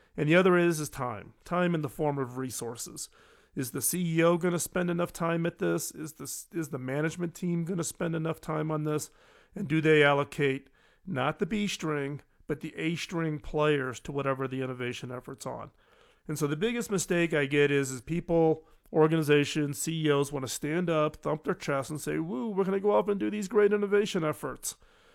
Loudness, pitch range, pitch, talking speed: -29 LUFS, 140-170 Hz, 155 Hz, 200 wpm